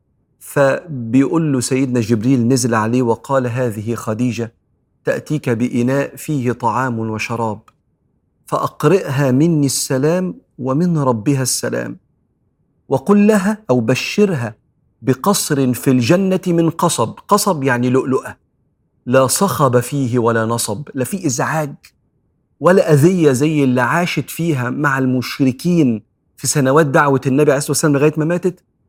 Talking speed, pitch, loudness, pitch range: 120 wpm, 135 Hz, -16 LUFS, 125-155 Hz